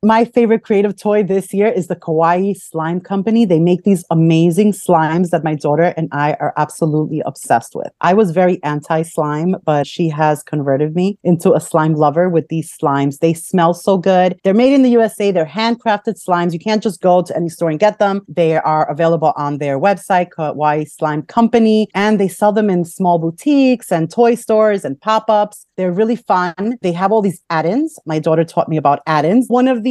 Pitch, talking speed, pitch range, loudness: 180 Hz, 205 wpm, 160-210 Hz, -15 LUFS